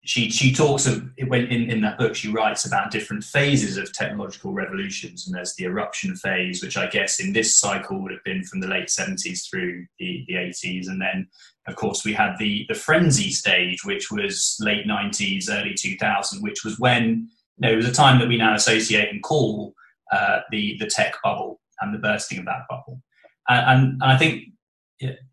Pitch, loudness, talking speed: 125 Hz, -21 LUFS, 210 wpm